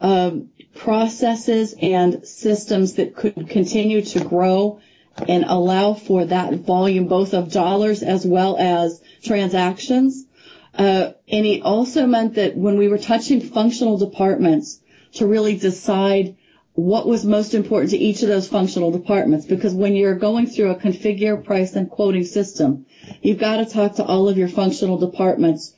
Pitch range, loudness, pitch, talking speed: 185-215 Hz, -18 LUFS, 200 Hz, 155 wpm